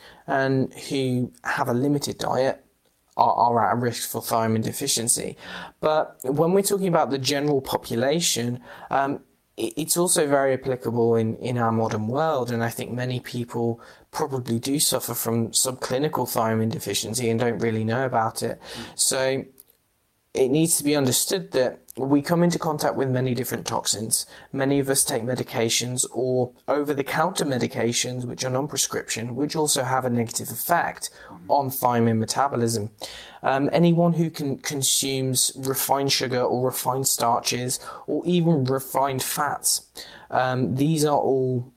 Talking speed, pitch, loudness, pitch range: 150 wpm, 130 Hz, -23 LUFS, 120-140 Hz